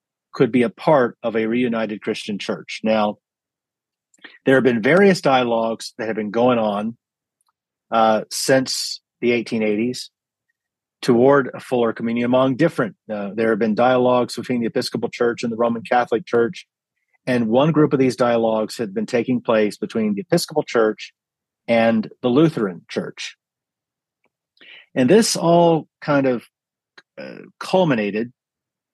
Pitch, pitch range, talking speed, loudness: 120 Hz, 115-135 Hz, 145 wpm, -19 LUFS